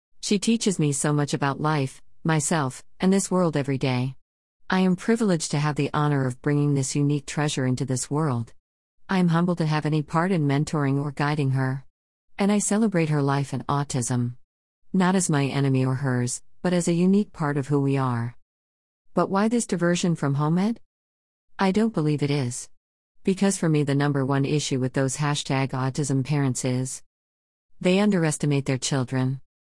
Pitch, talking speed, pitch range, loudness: 145 Hz, 185 wpm, 130-165 Hz, -24 LUFS